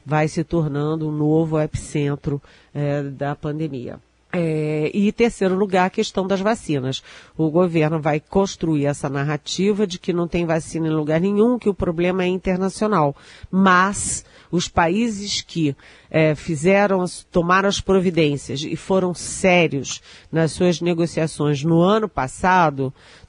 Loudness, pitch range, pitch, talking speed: -20 LUFS, 150-185 Hz, 165 Hz, 140 wpm